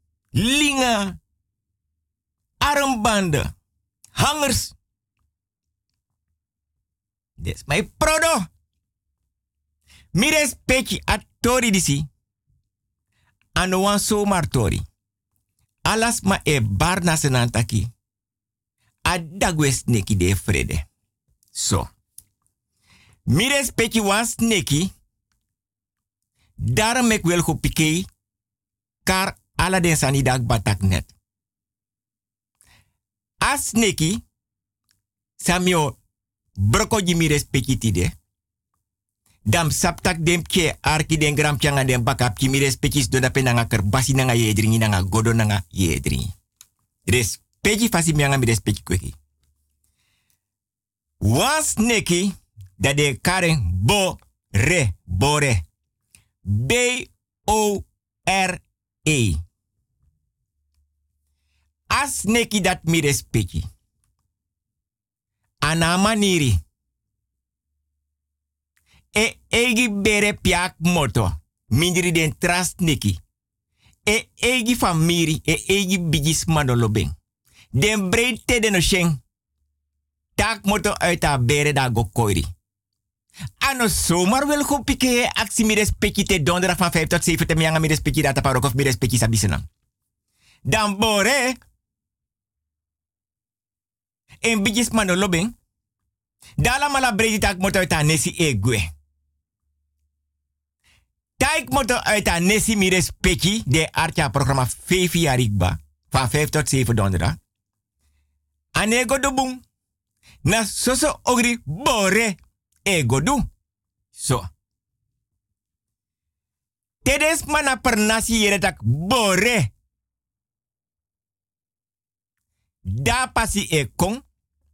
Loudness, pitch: -20 LUFS, 120 Hz